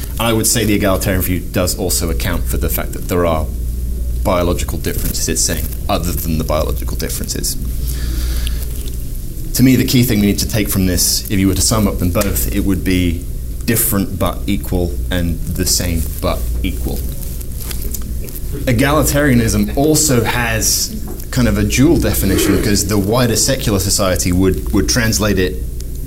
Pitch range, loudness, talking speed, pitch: 75-105 Hz, -16 LUFS, 165 wpm, 90 Hz